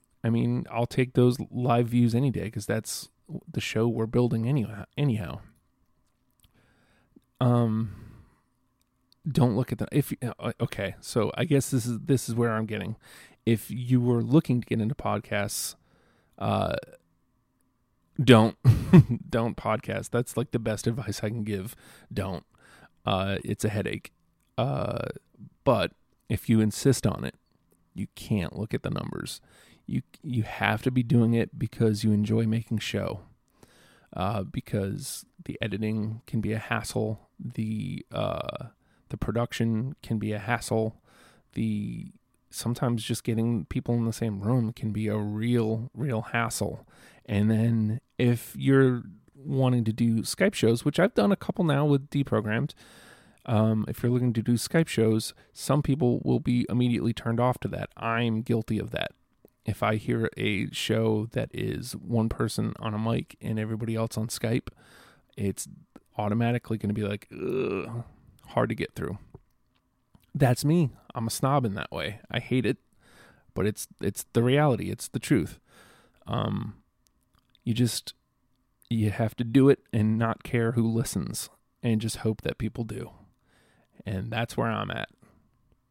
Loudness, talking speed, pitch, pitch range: -28 LUFS, 155 wpm, 115 Hz, 110-125 Hz